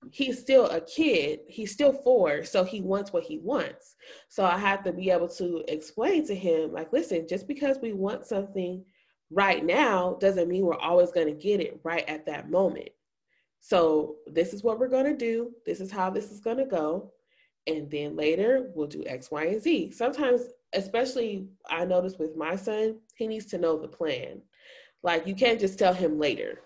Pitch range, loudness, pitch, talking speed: 175-250 Hz, -27 LUFS, 195 Hz, 200 wpm